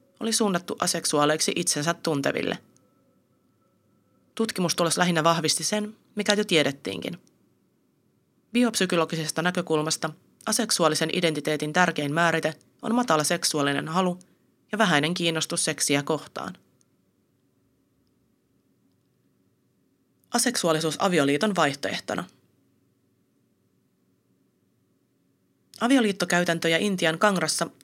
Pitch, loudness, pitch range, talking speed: 165 Hz, -24 LUFS, 150-190 Hz, 75 wpm